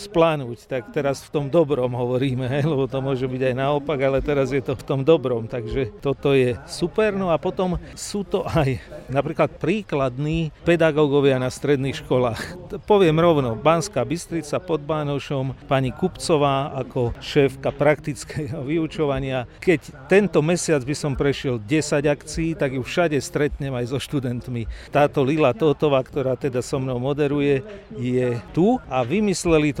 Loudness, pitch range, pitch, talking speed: -22 LUFS, 130-160 Hz, 145 Hz, 155 wpm